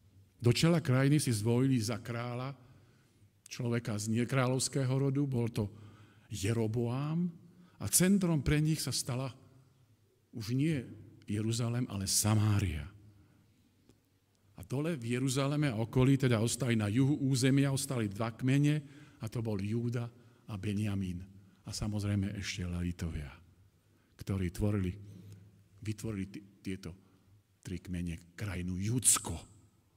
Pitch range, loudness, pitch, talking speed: 100-130 Hz, -33 LUFS, 115 Hz, 115 wpm